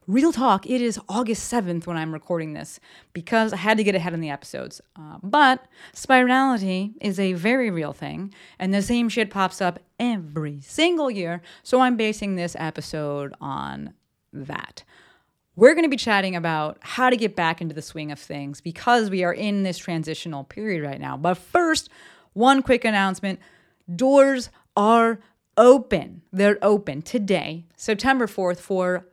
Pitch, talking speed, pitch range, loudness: 195 Hz, 165 wpm, 170-235 Hz, -22 LUFS